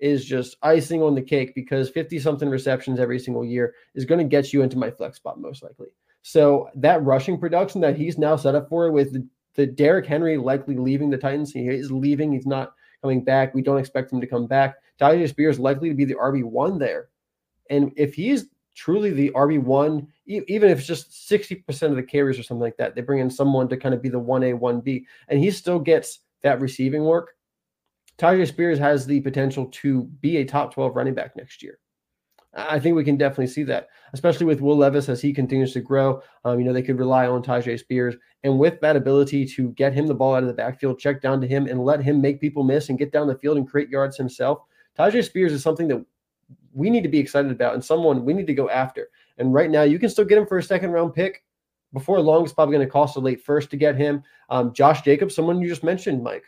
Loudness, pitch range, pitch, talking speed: -21 LUFS, 130-160 Hz, 140 Hz, 240 wpm